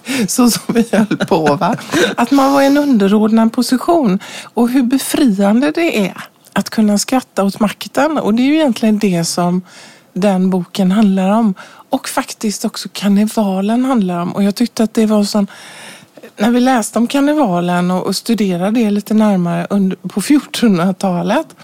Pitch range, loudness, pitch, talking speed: 195-250 Hz, -14 LUFS, 215 Hz, 160 wpm